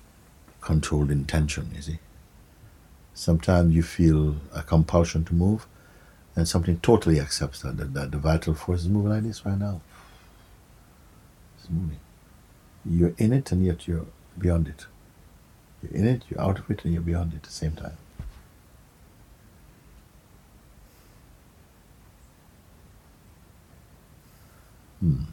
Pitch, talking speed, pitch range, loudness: 85 Hz, 125 wpm, 80-95 Hz, -25 LUFS